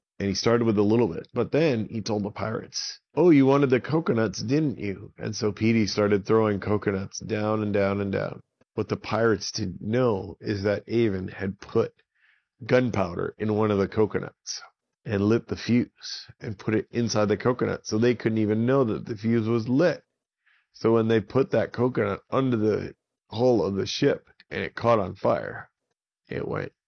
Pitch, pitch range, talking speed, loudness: 110 Hz, 105-120 Hz, 190 wpm, -25 LUFS